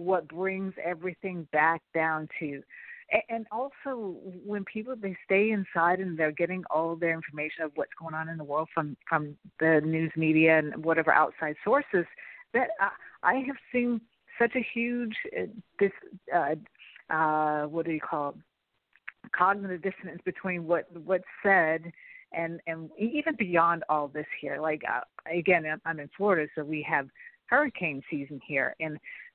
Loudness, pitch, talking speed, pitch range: -29 LUFS, 170 Hz, 160 wpm, 160-200 Hz